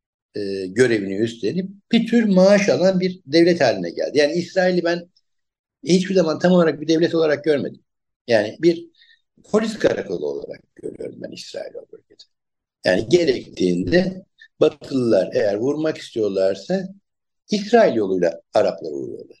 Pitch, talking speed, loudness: 190 Hz, 125 wpm, -19 LUFS